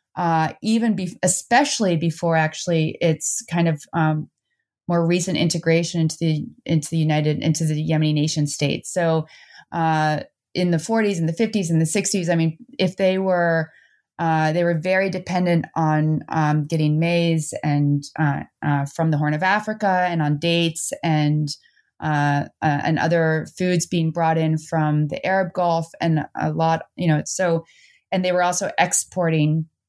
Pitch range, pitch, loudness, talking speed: 155-180 Hz, 165 Hz, -21 LUFS, 165 wpm